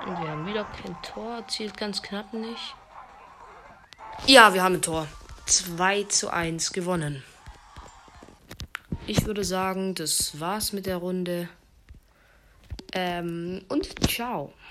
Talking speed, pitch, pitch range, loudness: 120 wpm, 185 Hz, 170-210 Hz, -25 LUFS